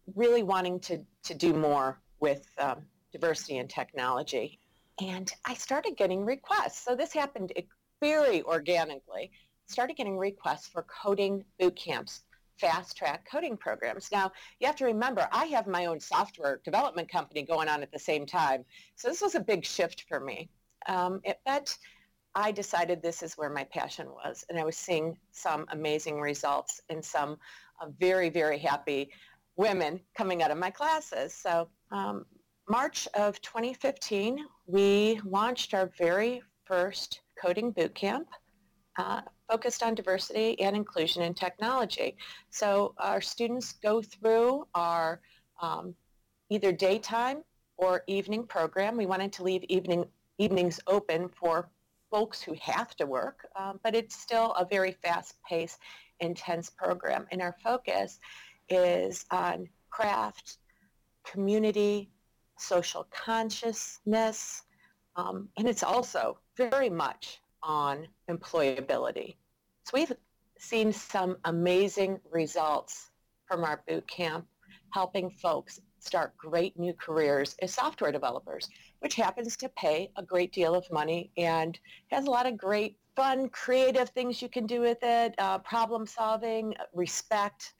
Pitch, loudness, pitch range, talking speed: 195 Hz, -31 LUFS, 170-225 Hz, 140 wpm